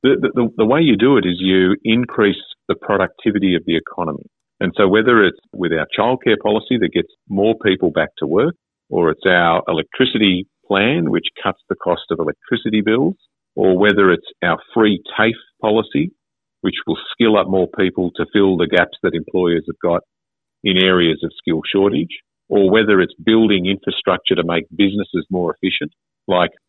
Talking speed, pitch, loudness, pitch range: 180 wpm, 95 Hz, -17 LUFS, 90-105 Hz